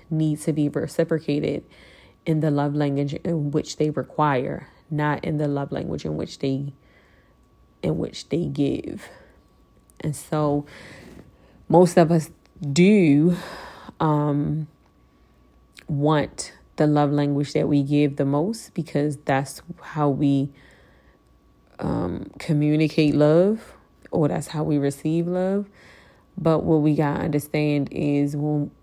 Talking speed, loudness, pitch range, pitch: 125 wpm, -23 LUFS, 145-160 Hz, 150 Hz